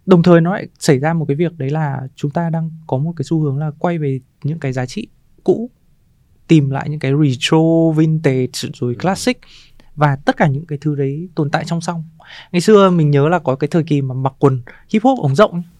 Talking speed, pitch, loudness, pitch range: 235 wpm, 155 Hz, -16 LUFS, 135-170 Hz